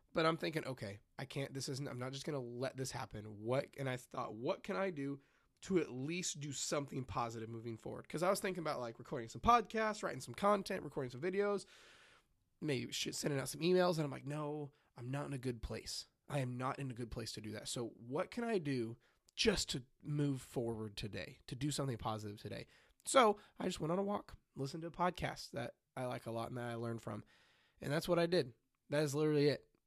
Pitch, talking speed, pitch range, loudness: 140 Hz, 235 wpm, 120-160 Hz, -40 LUFS